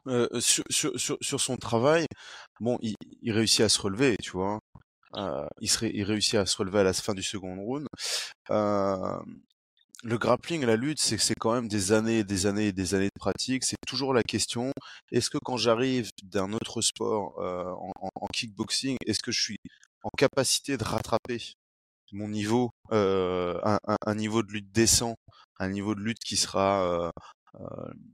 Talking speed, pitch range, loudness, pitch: 190 wpm, 100-120 Hz, -28 LUFS, 110 Hz